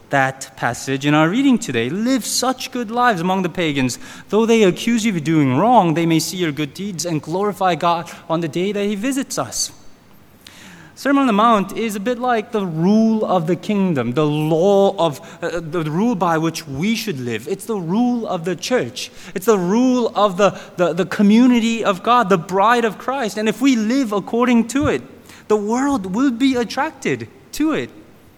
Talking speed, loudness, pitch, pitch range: 200 wpm, -18 LUFS, 200 Hz, 170-235 Hz